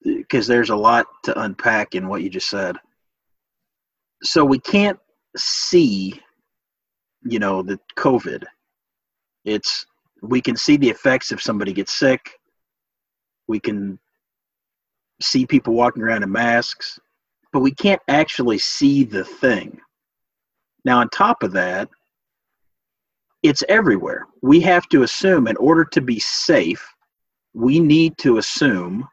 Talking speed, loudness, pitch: 130 wpm, -18 LUFS, 155 Hz